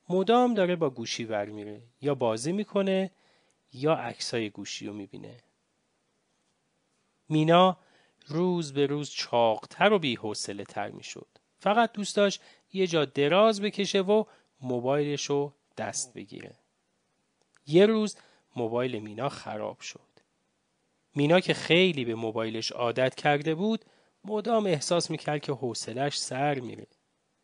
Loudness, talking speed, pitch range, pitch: -28 LUFS, 120 wpm, 125-185 Hz, 150 Hz